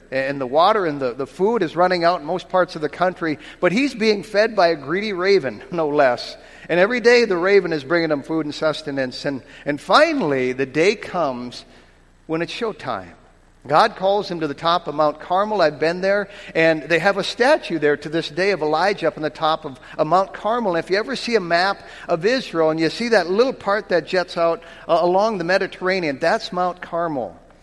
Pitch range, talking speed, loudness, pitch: 155-195 Hz, 220 wpm, -20 LUFS, 170 Hz